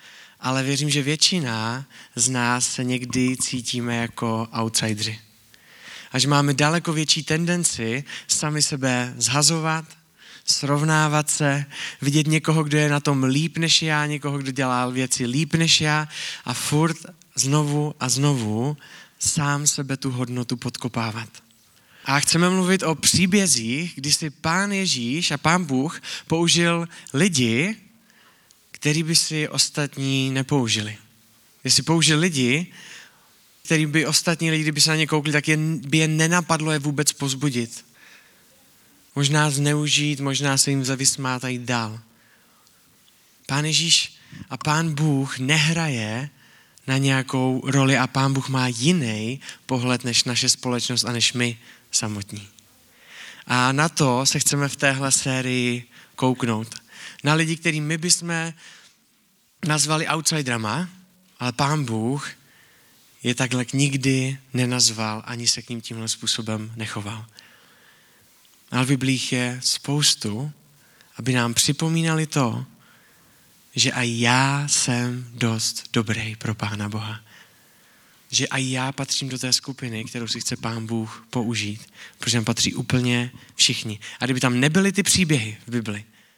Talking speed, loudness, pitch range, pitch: 130 wpm, -21 LUFS, 120-150 Hz, 135 Hz